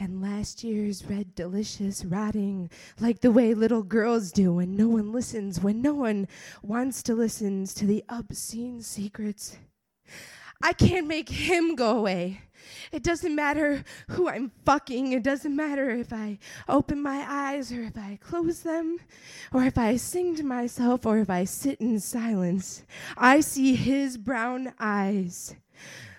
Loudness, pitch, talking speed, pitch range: -27 LUFS, 235 Hz, 155 wpm, 205-275 Hz